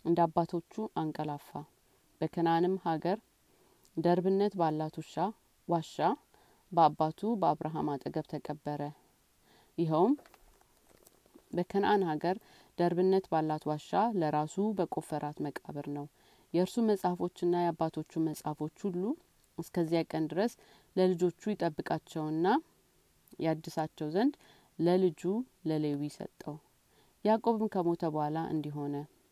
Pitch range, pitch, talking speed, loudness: 155-185 Hz, 170 Hz, 115 wpm, -33 LUFS